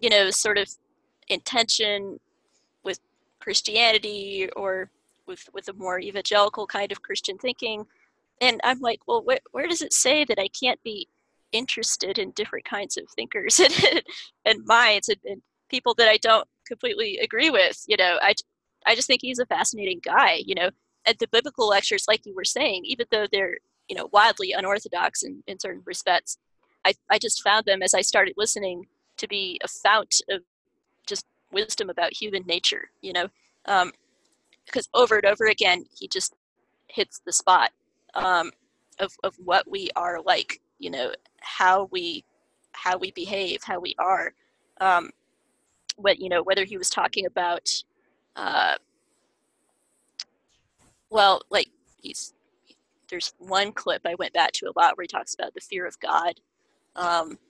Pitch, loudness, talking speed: 220 Hz, -23 LUFS, 165 wpm